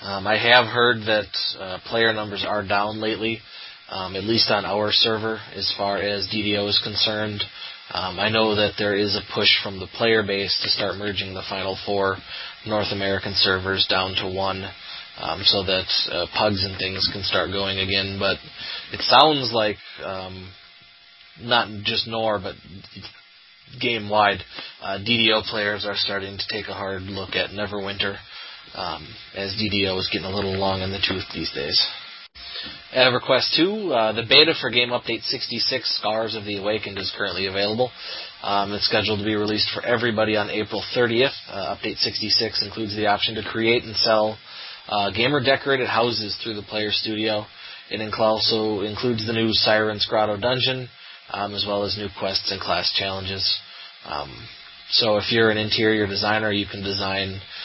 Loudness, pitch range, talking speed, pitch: -21 LUFS, 100-110 Hz, 170 wpm, 105 Hz